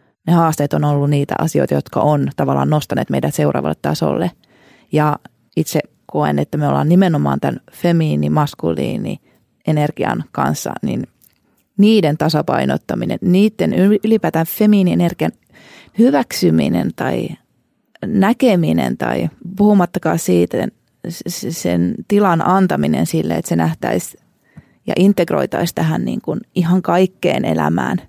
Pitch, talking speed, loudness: 155 Hz, 105 wpm, -16 LUFS